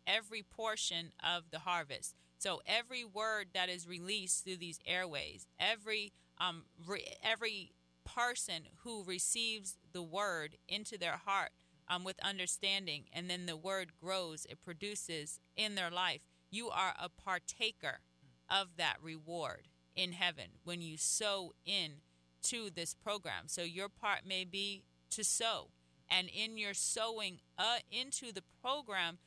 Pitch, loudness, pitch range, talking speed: 185 Hz, -39 LUFS, 165-205 Hz, 145 wpm